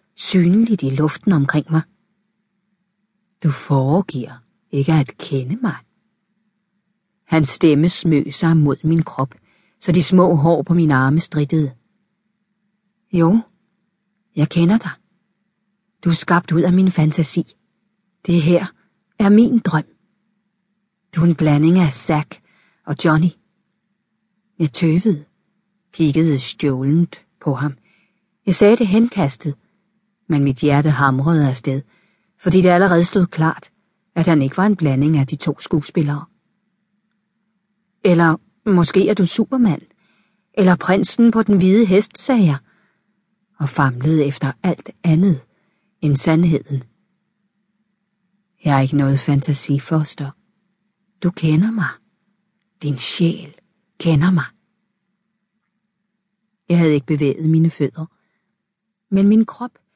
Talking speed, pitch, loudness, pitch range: 120 wpm, 190 Hz, -17 LUFS, 155-205 Hz